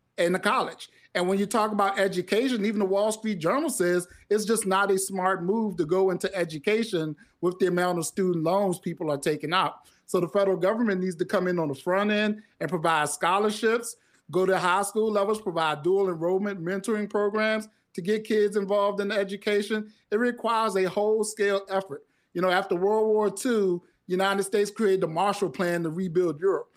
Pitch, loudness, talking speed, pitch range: 195 Hz, -26 LUFS, 195 wpm, 180-210 Hz